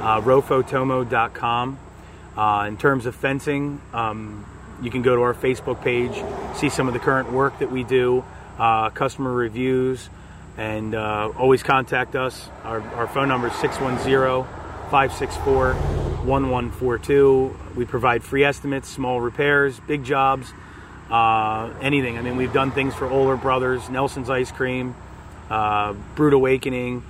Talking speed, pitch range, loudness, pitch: 140 wpm, 110-135 Hz, -21 LUFS, 125 Hz